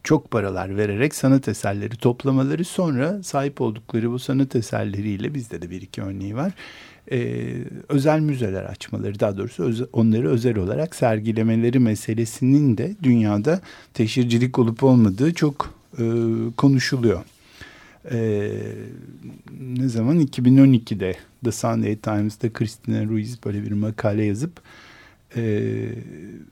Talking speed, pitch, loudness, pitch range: 120 wpm, 115 Hz, -22 LUFS, 110-135 Hz